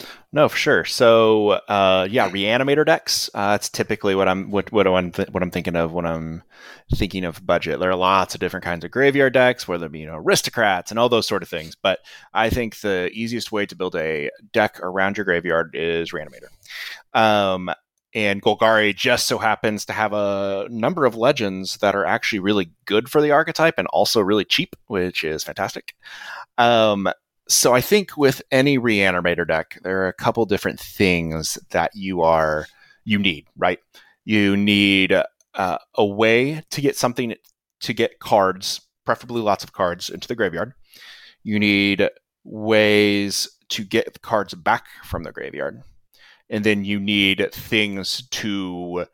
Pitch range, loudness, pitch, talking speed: 90-110 Hz, -20 LUFS, 100 Hz, 175 wpm